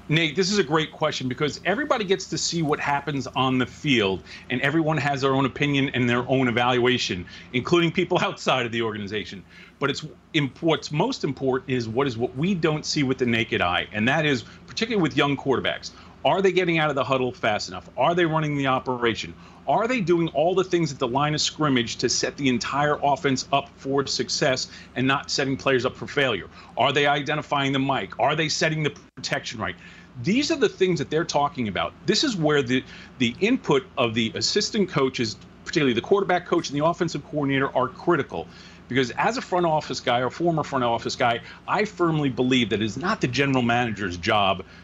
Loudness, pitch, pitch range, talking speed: -23 LUFS, 140 Hz, 125-165 Hz, 210 wpm